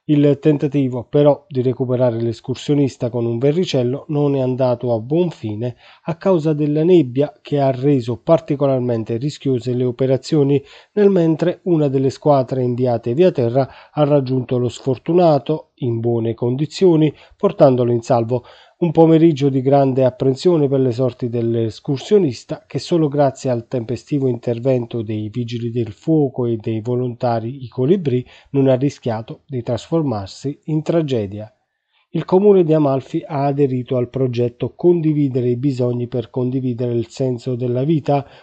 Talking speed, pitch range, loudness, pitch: 145 wpm, 125-150 Hz, -18 LUFS, 135 Hz